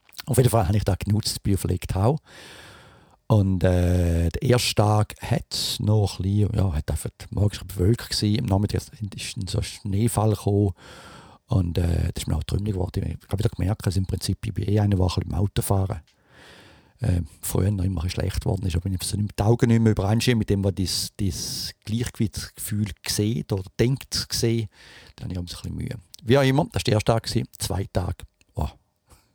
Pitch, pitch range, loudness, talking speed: 100 Hz, 95-110 Hz, -24 LUFS, 195 wpm